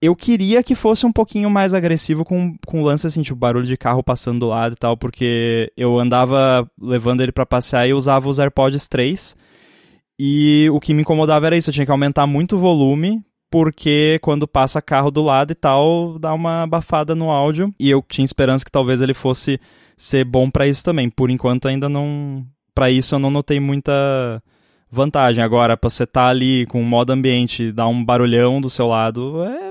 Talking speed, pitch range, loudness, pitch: 210 wpm, 125-155 Hz, -16 LUFS, 135 Hz